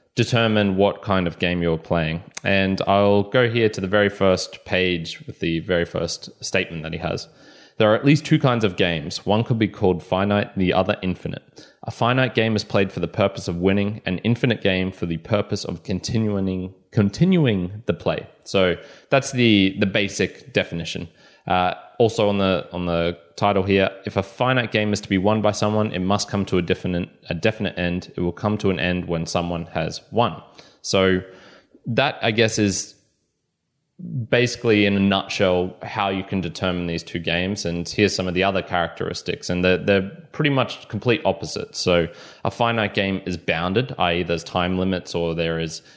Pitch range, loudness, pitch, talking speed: 90-105 Hz, -21 LUFS, 95 Hz, 190 wpm